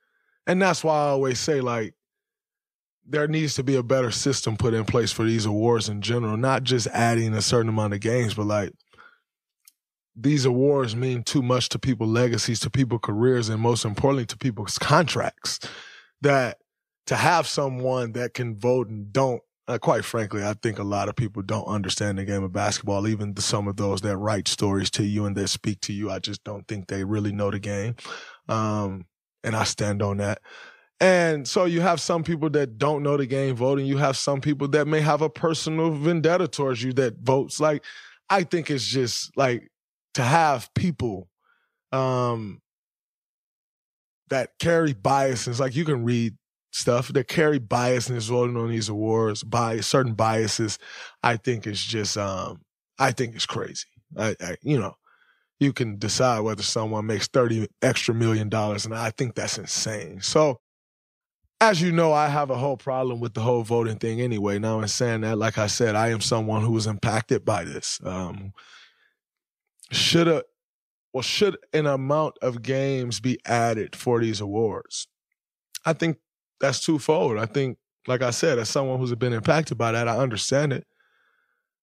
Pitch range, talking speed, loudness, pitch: 110-140 Hz, 185 wpm, -24 LUFS, 120 Hz